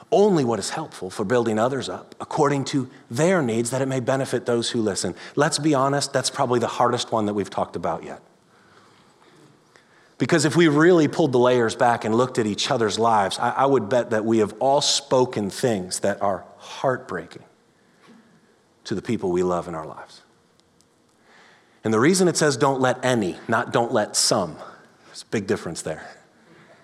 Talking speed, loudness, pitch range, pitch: 190 wpm, -22 LUFS, 115-145 Hz, 130 Hz